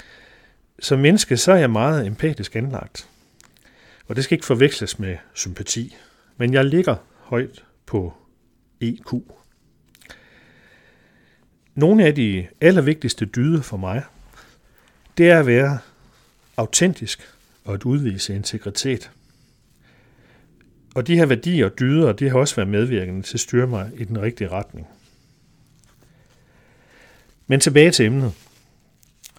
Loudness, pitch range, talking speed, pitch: -19 LUFS, 110-145 Hz, 125 wpm, 125 Hz